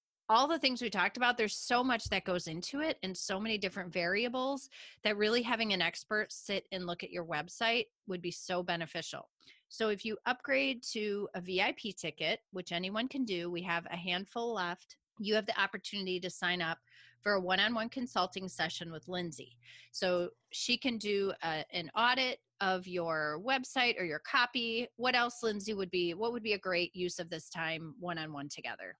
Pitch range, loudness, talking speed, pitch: 175-230 Hz, -34 LUFS, 190 wpm, 195 Hz